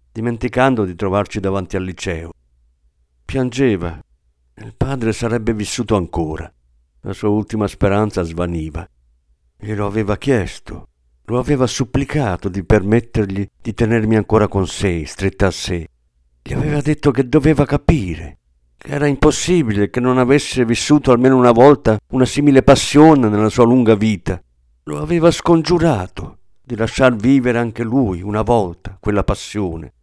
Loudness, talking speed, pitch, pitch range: -16 LUFS, 135 wpm, 105 Hz, 90-130 Hz